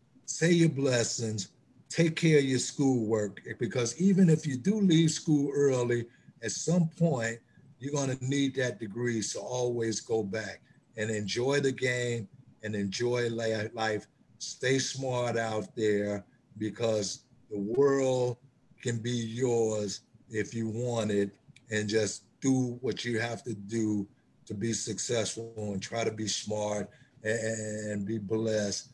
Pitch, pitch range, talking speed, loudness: 120 Hz, 110-130 Hz, 140 wpm, -30 LUFS